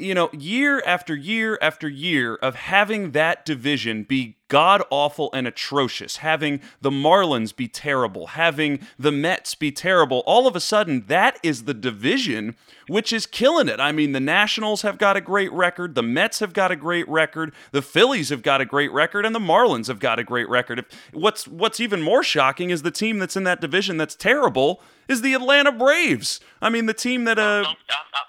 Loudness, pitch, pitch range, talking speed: -20 LUFS, 170 Hz, 145-215 Hz, 195 wpm